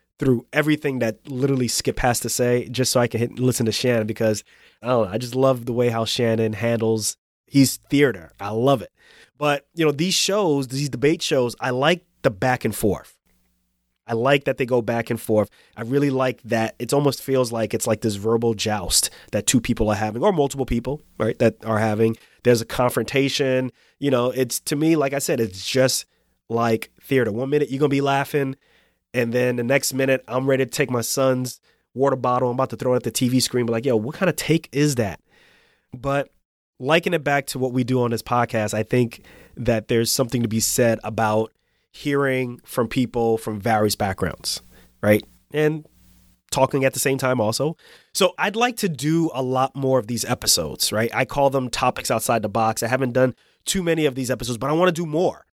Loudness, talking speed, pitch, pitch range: -21 LUFS, 215 wpm, 125 Hz, 115-140 Hz